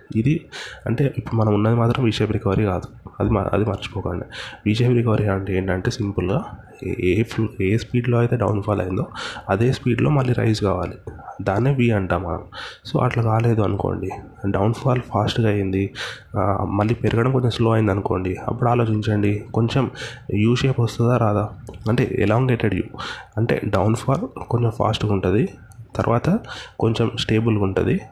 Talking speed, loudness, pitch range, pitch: 140 wpm, -21 LUFS, 100-120 Hz, 110 Hz